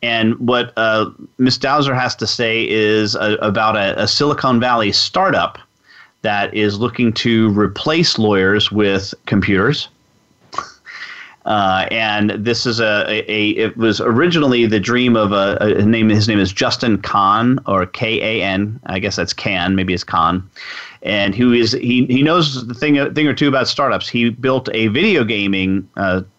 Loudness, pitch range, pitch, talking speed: -15 LUFS, 105-125 Hz, 110 Hz, 165 wpm